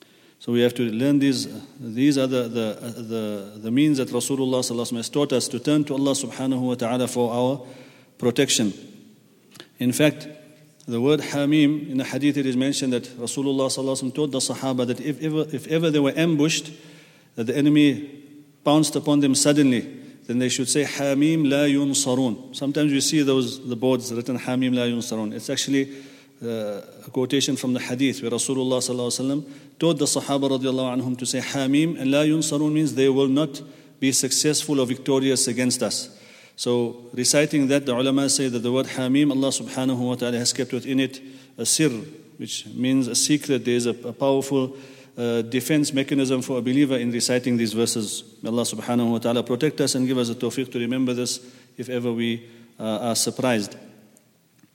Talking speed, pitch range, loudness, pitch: 185 wpm, 125-140 Hz, -22 LUFS, 130 Hz